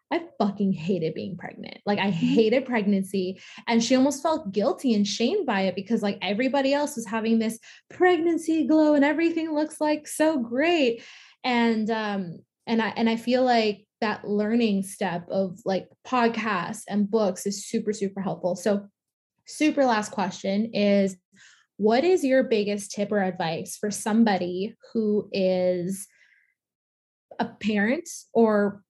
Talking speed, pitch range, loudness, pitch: 150 wpm, 200-255 Hz, -25 LUFS, 220 Hz